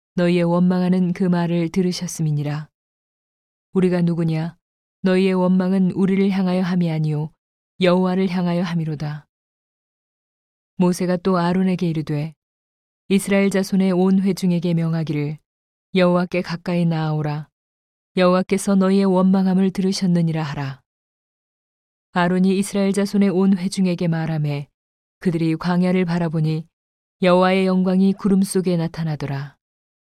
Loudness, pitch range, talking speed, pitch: -20 LUFS, 160-190 Hz, 305 characters per minute, 180 Hz